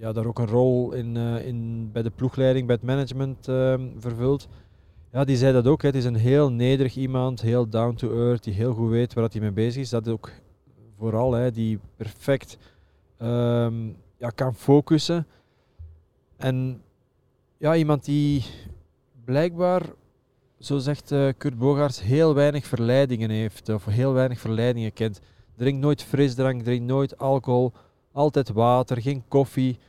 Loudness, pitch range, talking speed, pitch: -24 LUFS, 115-135 Hz, 155 wpm, 125 Hz